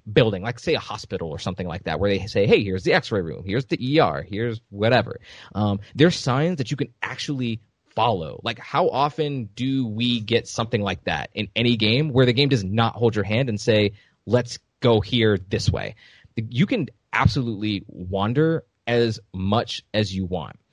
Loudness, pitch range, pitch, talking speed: -23 LUFS, 100-130 Hz, 115 Hz, 190 wpm